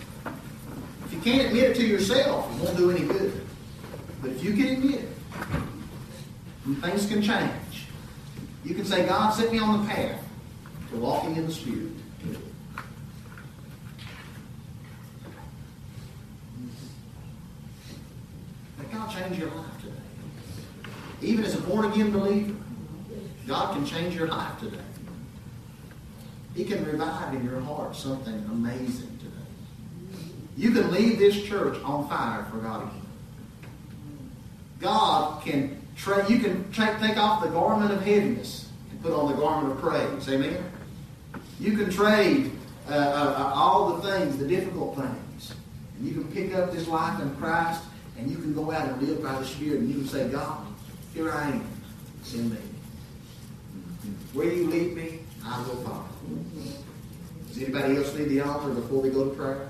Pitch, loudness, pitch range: 155 Hz, -27 LUFS, 130-200 Hz